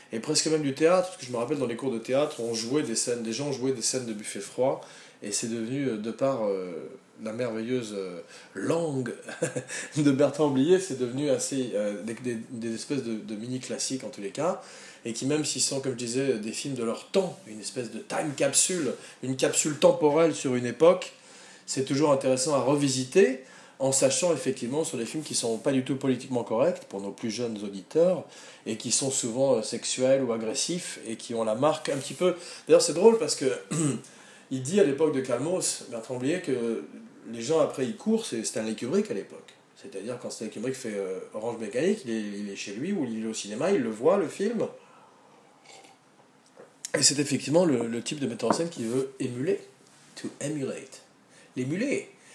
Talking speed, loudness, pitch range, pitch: 205 wpm, -27 LUFS, 115-150 Hz, 130 Hz